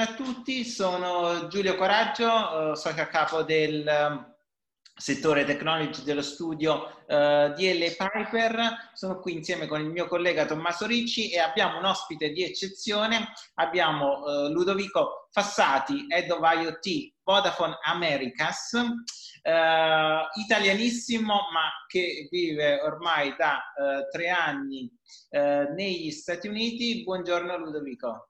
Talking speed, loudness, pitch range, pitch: 125 wpm, -26 LUFS, 155-220 Hz, 175 Hz